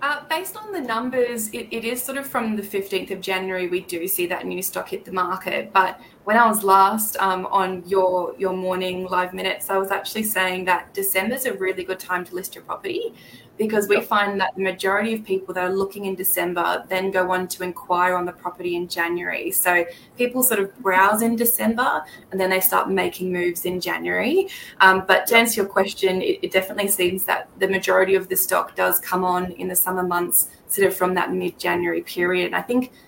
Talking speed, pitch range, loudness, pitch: 220 wpm, 180-215 Hz, -21 LUFS, 190 Hz